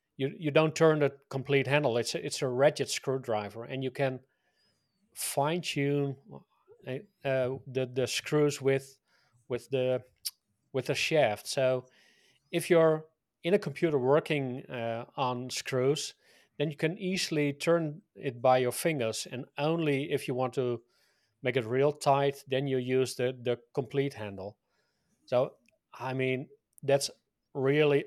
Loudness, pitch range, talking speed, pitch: -30 LUFS, 130-150 Hz, 150 wpm, 135 Hz